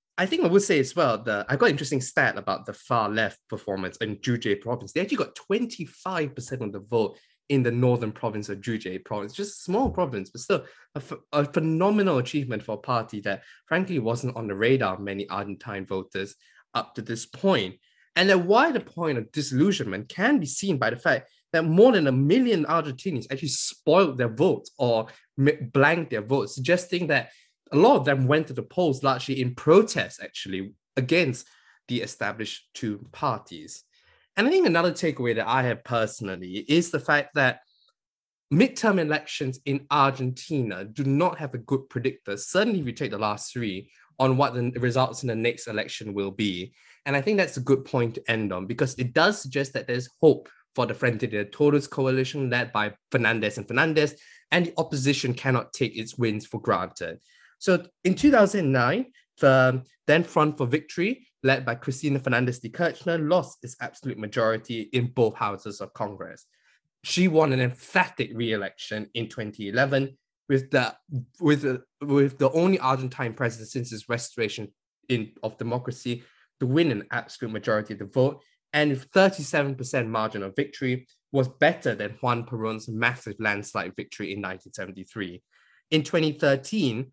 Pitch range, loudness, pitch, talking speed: 115-150 Hz, -25 LUFS, 130 Hz, 175 wpm